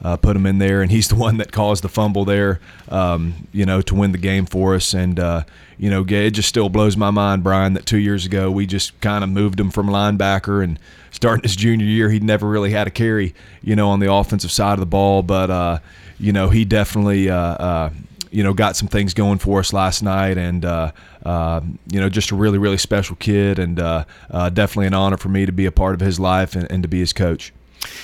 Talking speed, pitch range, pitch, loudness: 250 wpm, 90-105 Hz, 95 Hz, -18 LUFS